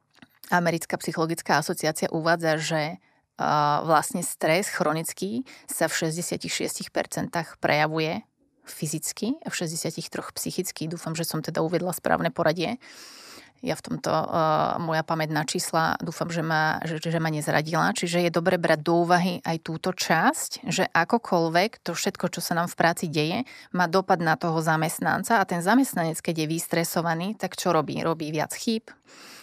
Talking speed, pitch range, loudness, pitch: 155 wpm, 160-185 Hz, -25 LUFS, 170 Hz